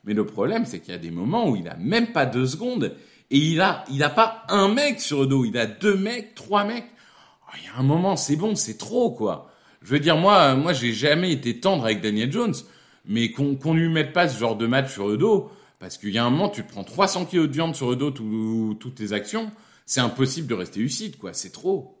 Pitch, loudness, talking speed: 150 Hz, -23 LUFS, 260 wpm